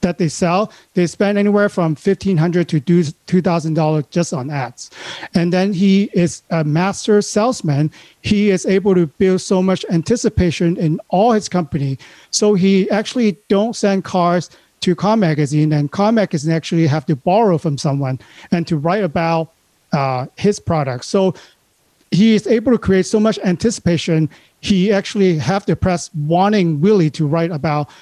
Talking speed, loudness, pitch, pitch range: 165 wpm, -16 LUFS, 180 Hz, 165-200 Hz